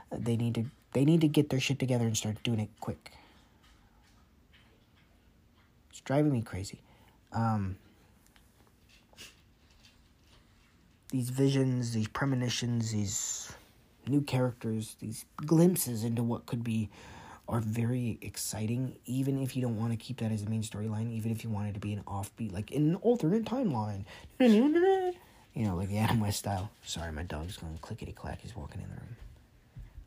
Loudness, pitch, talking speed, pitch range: -32 LUFS, 110 Hz, 155 wpm, 100-125 Hz